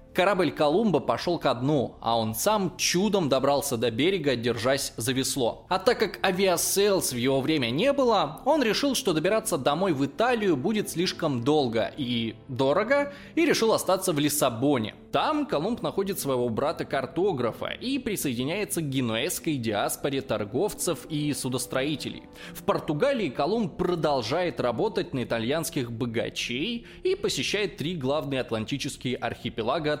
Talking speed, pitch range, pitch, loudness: 135 wpm, 130-195 Hz, 150 Hz, -26 LUFS